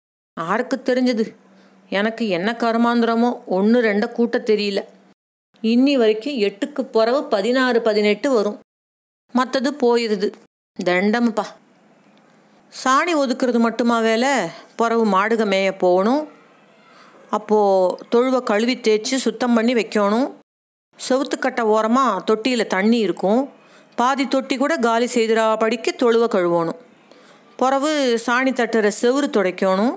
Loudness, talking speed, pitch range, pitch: -19 LUFS, 100 wpm, 210-255 Hz, 230 Hz